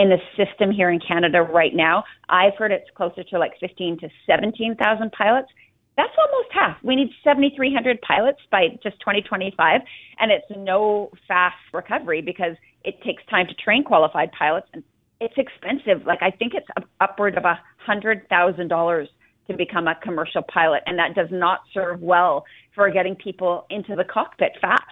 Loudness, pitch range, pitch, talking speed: -21 LUFS, 175-225 Hz, 195 Hz, 175 wpm